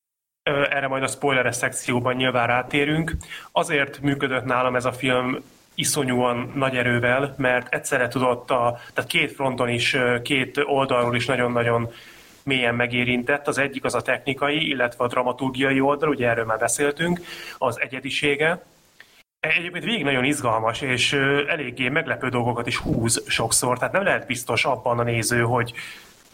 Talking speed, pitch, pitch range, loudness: 145 wpm, 130 Hz, 120-140 Hz, -22 LUFS